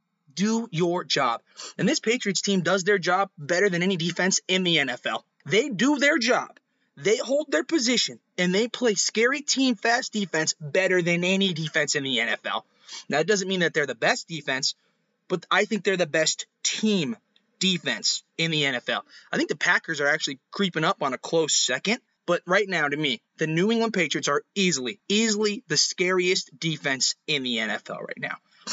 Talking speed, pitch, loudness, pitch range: 190 wpm, 185 Hz, -24 LUFS, 160-220 Hz